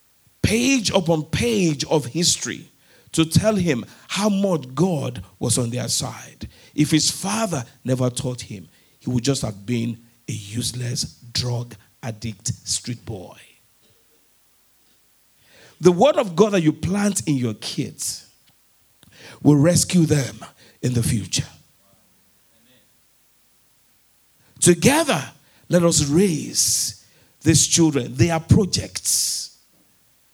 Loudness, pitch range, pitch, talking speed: -20 LUFS, 120-170 Hz, 135 Hz, 115 wpm